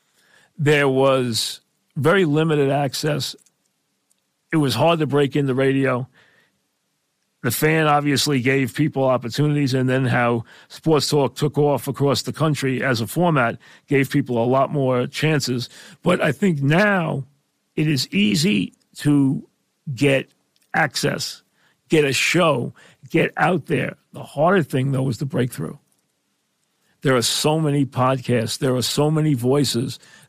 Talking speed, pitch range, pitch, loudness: 140 wpm, 130-155 Hz, 140 Hz, -20 LUFS